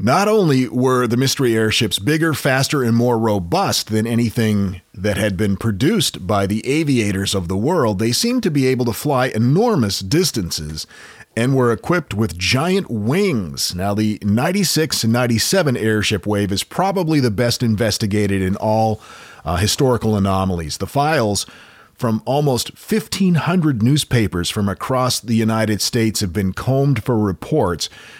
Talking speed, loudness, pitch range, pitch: 150 wpm, -18 LUFS, 105-135 Hz, 115 Hz